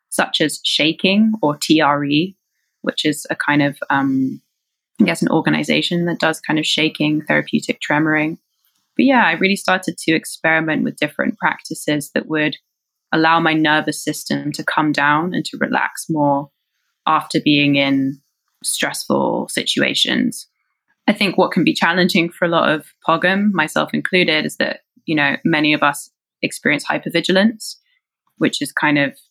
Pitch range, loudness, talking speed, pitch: 150-175 Hz, -17 LUFS, 155 wpm, 155 Hz